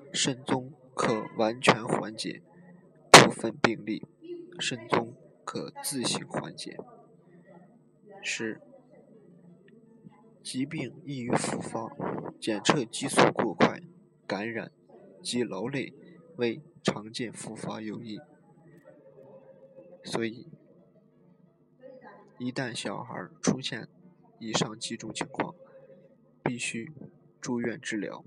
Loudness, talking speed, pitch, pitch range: -28 LUFS, 135 characters per minute, 165 Hz, 125-190 Hz